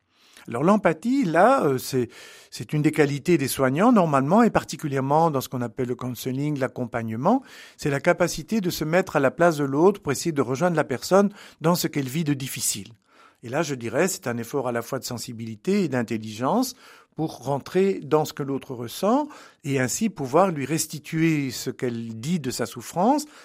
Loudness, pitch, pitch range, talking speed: -24 LUFS, 145 Hz, 125-175 Hz, 190 wpm